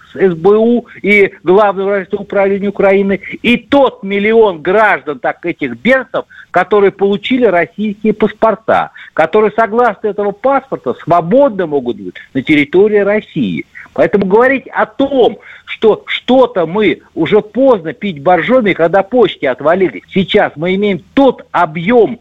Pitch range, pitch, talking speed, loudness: 185-230 Hz, 205 Hz, 120 wpm, -12 LUFS